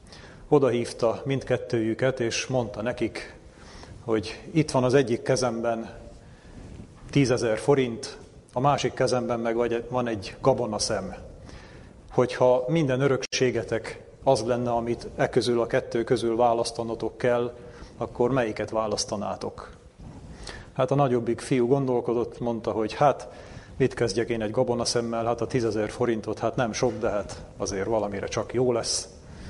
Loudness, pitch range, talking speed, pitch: -26 LUFS, 115-125 Hz, 130 wpm, 120 Hz